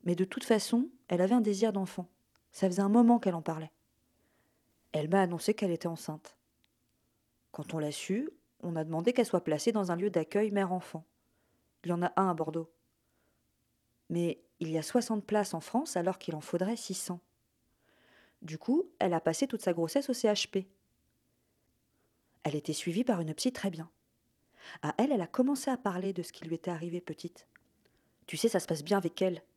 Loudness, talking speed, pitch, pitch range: -32 LUFS, 195 wpm, 185 Hz, 165-210 Hz